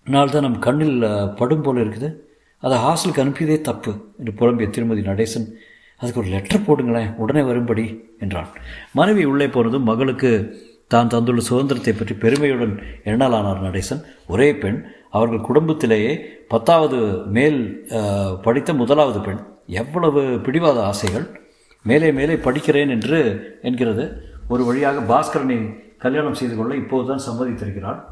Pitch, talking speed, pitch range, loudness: 120 Hz, 120 wpm, 110-140 Hz, -19 LUFS